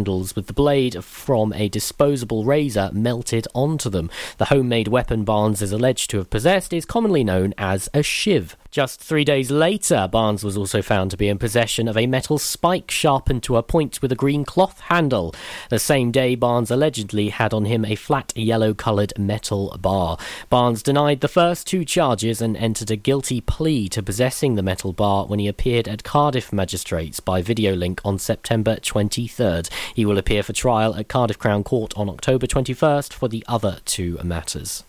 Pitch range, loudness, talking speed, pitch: 105-135 Hz, -20 LUFS, 185 wpm, 115 Hz